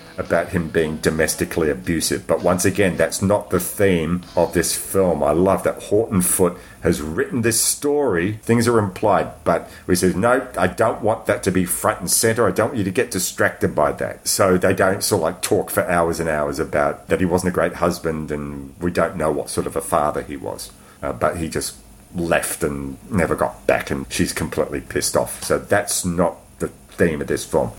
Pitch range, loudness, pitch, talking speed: 80-100 Hz, -20 LUFS, 90 Hz, 215 wpm